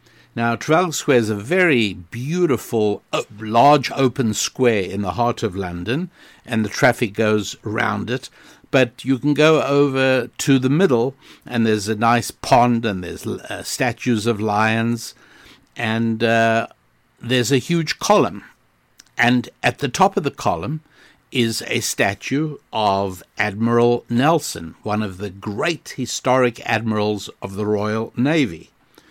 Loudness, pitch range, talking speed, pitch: -19 LUFS, 110-135 Hz, 140 wpm, 120 Hz